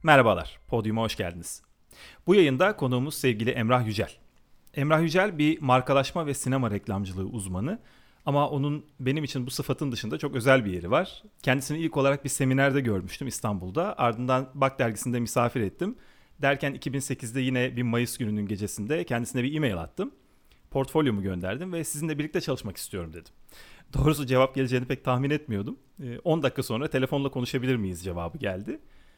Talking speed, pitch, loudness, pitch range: 155 wpm, 130 Hz, -27 LUFS, 115-140 Hz